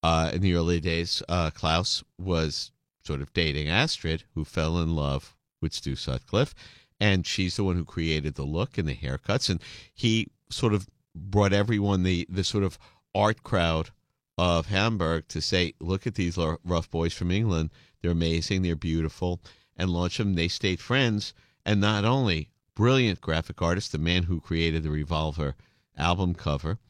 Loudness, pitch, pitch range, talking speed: -27 LUFS, 90 Hz, 80-100 Hz, 175 wpm